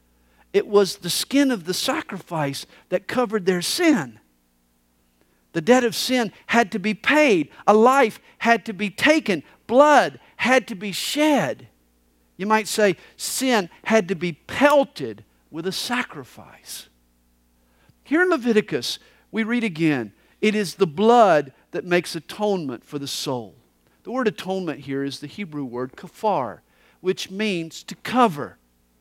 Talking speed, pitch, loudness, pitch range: 145 wpm, 195 Hz, -21 LUFS, 140-230 Hz